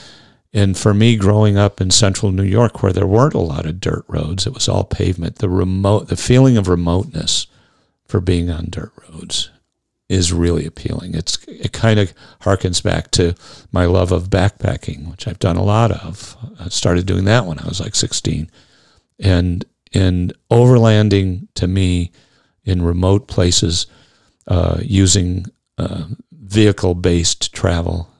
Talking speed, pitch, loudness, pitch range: 160 wpm, 95 Hz, -16 LUFS, 90-105 Hz